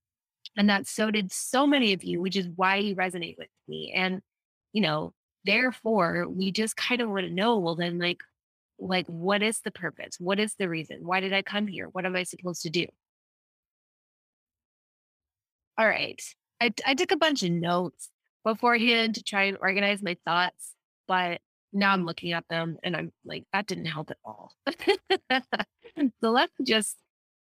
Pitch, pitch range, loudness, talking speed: 190 Hz, 175-220 Hz, -27 LUFS, 180 wpm